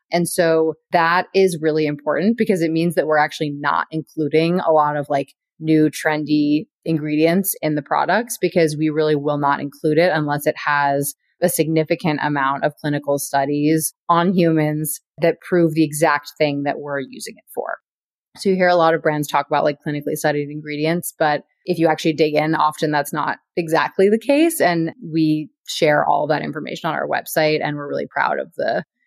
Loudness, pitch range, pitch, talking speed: -19 LUFS, 150-165 Hz, 155 Hz, 190 wpm